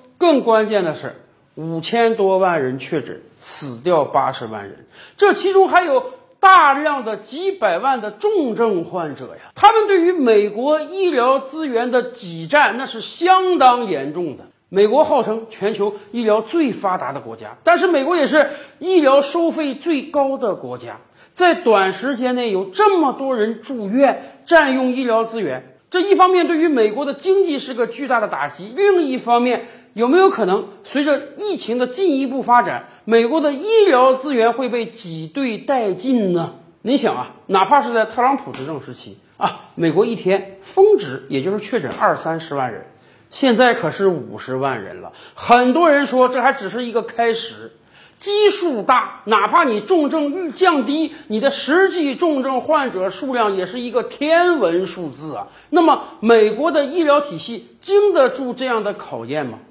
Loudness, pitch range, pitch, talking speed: -17 LUFS, 215-315 Hz, 255 Hz, 255 characters per minute